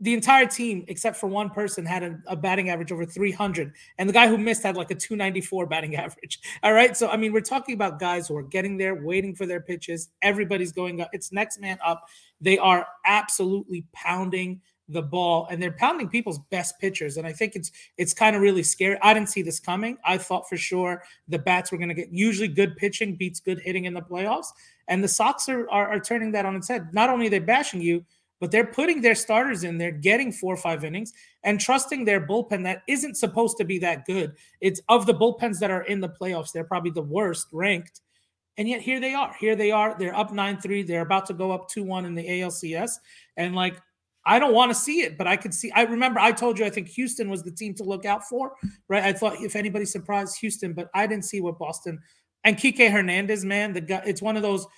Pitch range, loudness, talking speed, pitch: 180-215 Hz, -24 LUFS, 240 wpm, 195 Hz